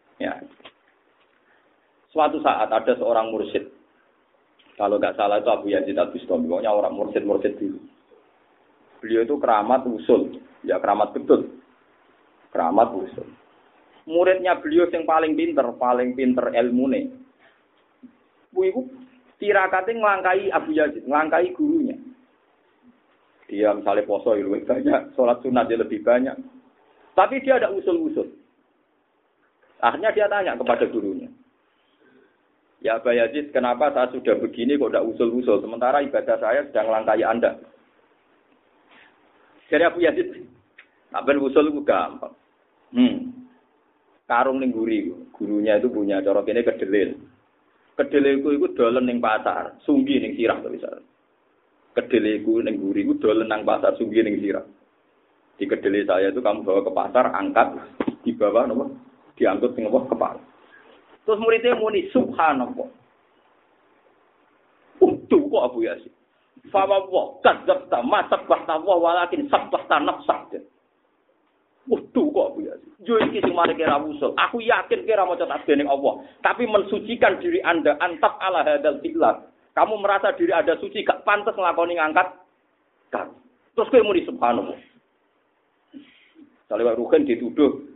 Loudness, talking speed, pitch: -22 LUFS, 125 wpm, 240 Hz